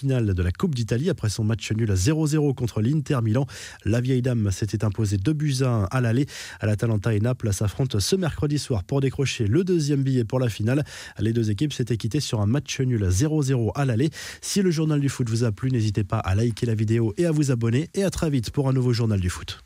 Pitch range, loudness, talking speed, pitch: 110-140 Hz, -24 LUFS, 245 wpm, 120 Hz